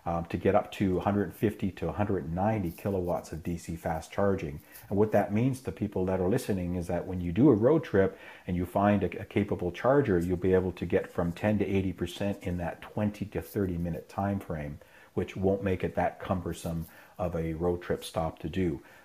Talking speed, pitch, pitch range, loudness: 210 wpm, 95 Hz, 85-100 Hz, -30 LUFS